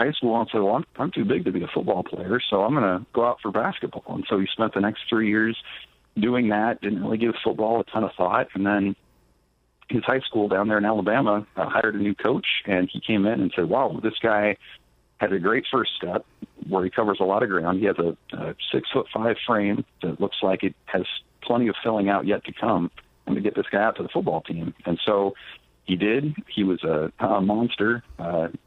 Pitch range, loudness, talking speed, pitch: 95-110 Hz, -24 LUFS, 240 wpm, 105 Hz